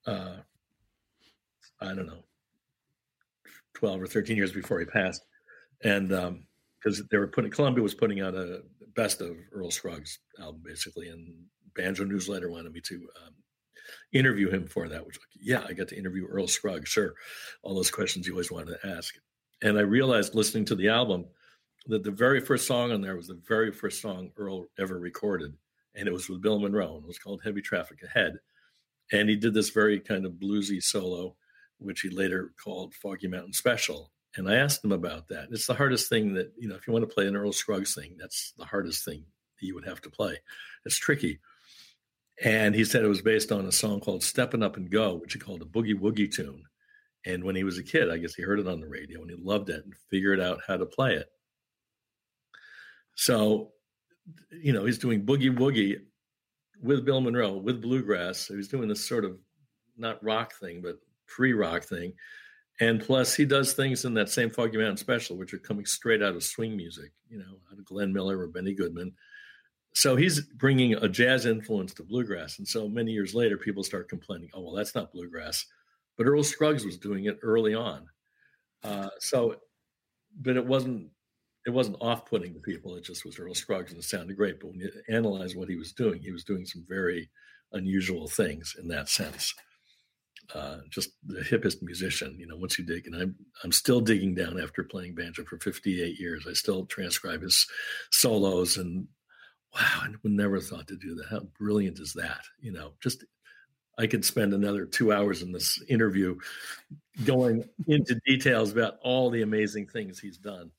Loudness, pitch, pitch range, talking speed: -28 LUFS, 105 Hz, 95-125 Hz, 200 wpm